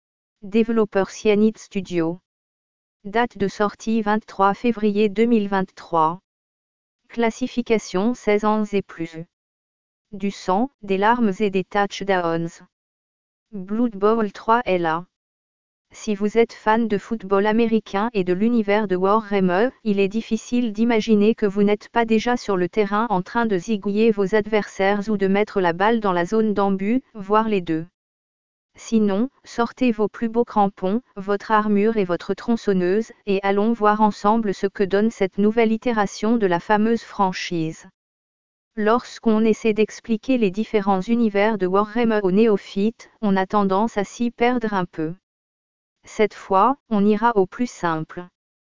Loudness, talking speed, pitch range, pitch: -21 LUFS, 145 wpm, 195-225 Hz, 210 Hz